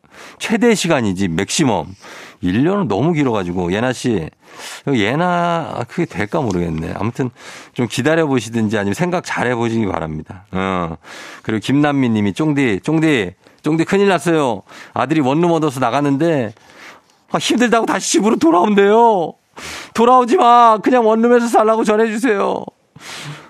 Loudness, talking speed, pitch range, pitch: -16 LUFS, 310 characters per minute, 110-185 Hz, 150 Hz